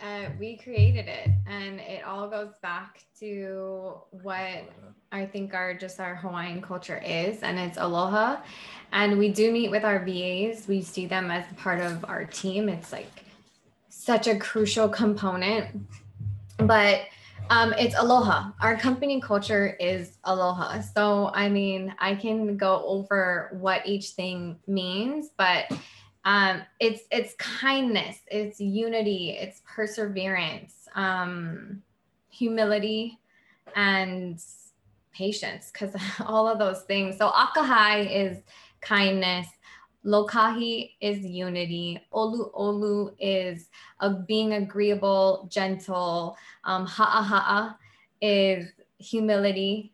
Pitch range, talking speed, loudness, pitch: 185-215 Hz, 120 wpm, -26 LUFS, 200 Hz